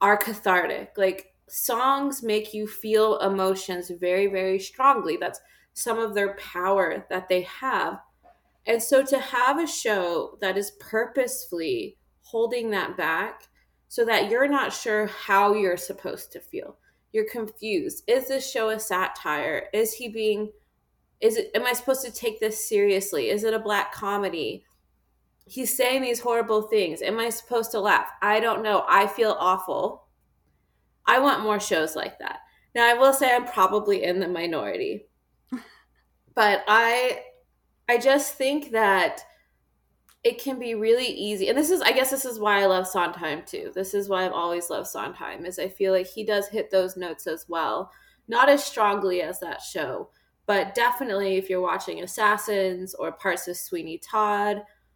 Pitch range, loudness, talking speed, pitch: 190-255 Hz, -24 LUFS, 170 wpm, 215 Hz